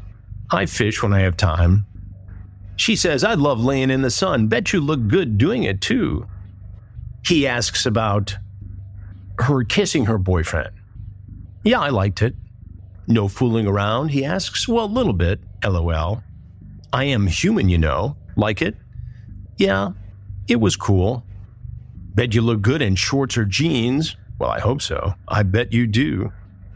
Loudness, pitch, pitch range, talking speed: -19 LUFS, 100 Hz, 95-115 Hz, 155 wpm